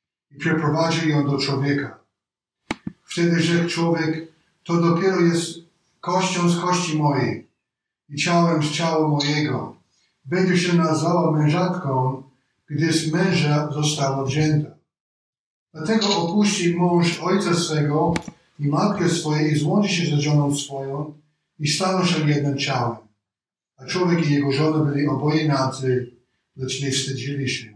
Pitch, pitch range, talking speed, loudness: 155 Hz, 140-170 Hz, 130 wpm, -21 LUFS